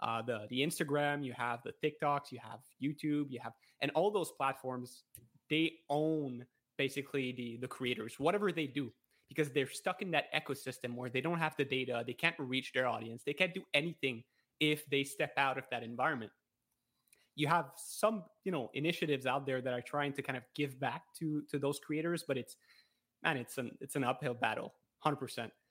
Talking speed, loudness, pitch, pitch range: 200 wpm, -37 LUFS, 140 Hz, 125-155 Hz